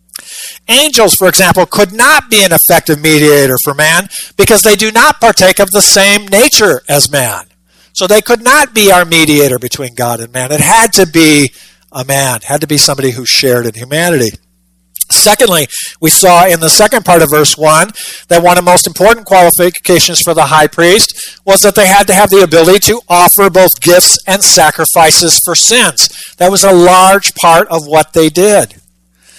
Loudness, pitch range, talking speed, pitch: -6 LUFS, 150-200 Hz, 190 wpm, 175 Hz